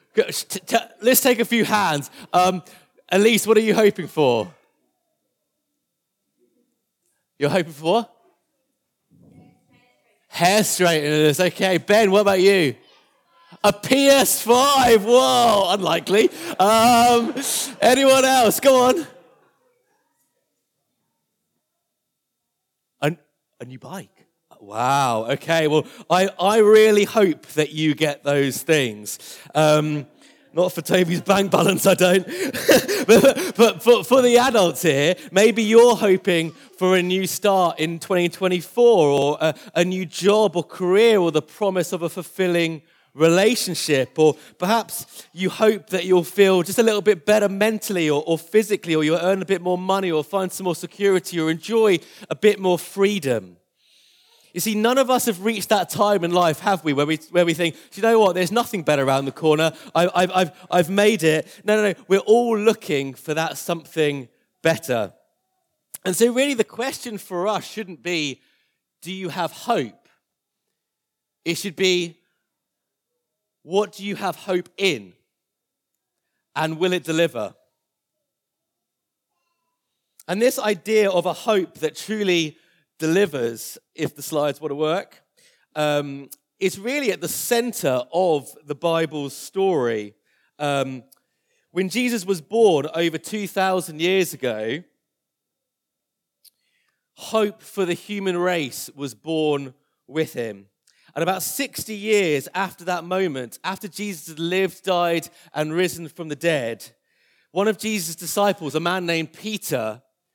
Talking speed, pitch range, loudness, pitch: 140 wpm, 160-210 Hz, -20 LUFS, 185 Hz